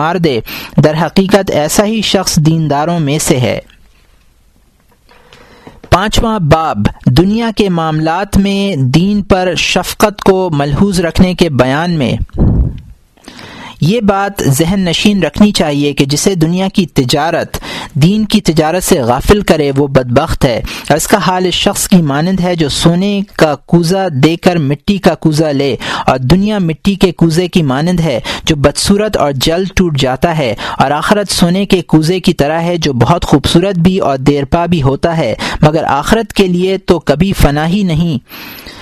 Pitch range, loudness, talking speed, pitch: 150-195 Hz, -11 LUFS, 160 wpm, 175 Hz